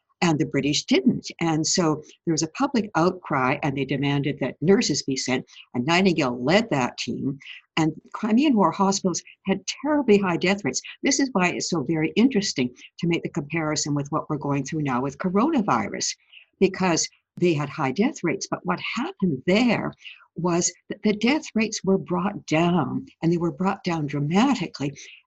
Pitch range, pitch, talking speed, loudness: 150-200 Hz, 170 Hz, 180 wpm, -24 LUFS